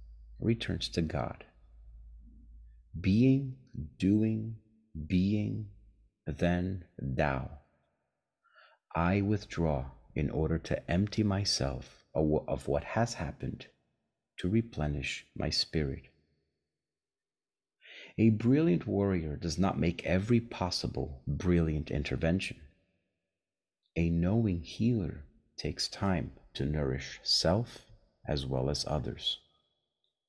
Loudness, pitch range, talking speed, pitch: -32 LUFS, 70-100 Hz, 90 wpm, 85 Hz